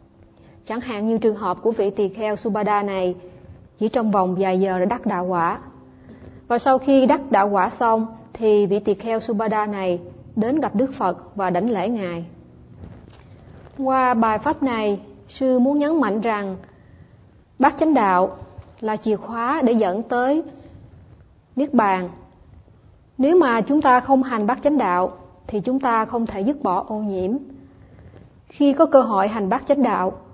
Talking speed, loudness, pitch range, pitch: 170 wpm, -20 LUFS, 200-260 Hz, 225 Hz